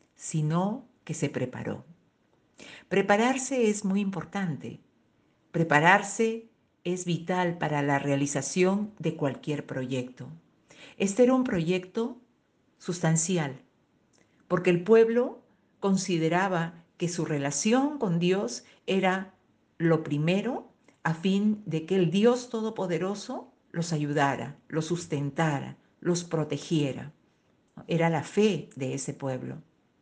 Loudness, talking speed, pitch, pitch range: -28 LUFS, 105 wpm, 175 Hz, 155-200 Hz